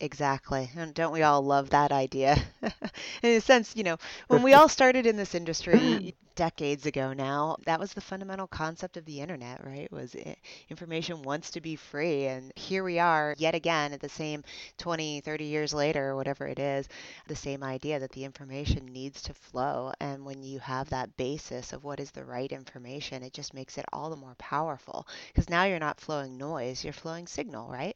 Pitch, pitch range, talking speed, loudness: 150 Hz, 135-165 Hz, 200 wpm, -29 LUFS